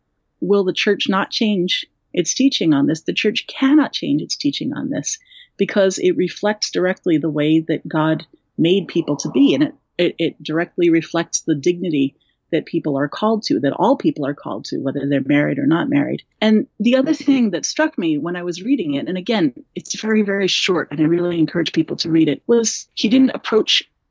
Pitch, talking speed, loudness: 195 Hz, 210 wpm, -18 LUFS